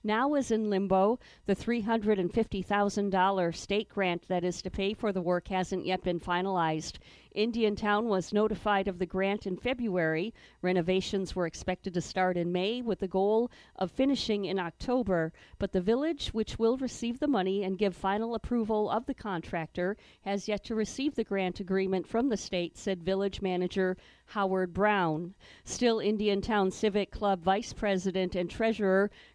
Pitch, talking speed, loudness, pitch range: 195 Hz, 165 wpm, -31 LUFS, 185-215 Hz